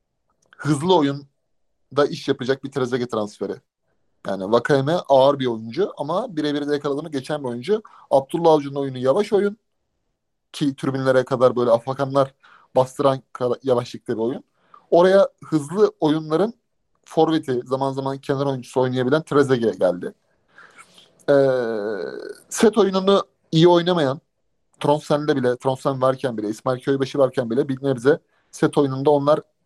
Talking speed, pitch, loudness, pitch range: 125 wpm, 140 Hz, -21 LUFS, 130-155 Hz